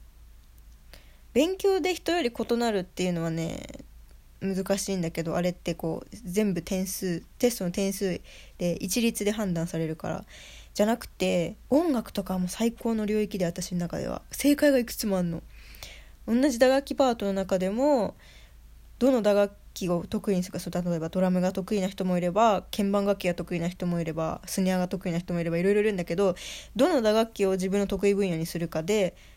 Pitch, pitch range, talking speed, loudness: 190 Hz, 175-215 Hz, 365 characters per minute, -27 LUFS